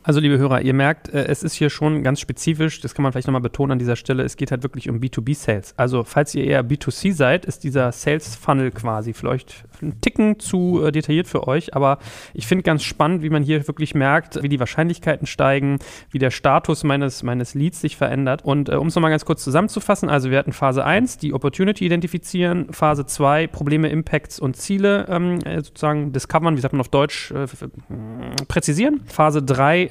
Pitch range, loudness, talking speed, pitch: 135-160 Hz, -20 LUFS, 205 wpm, 145 Hz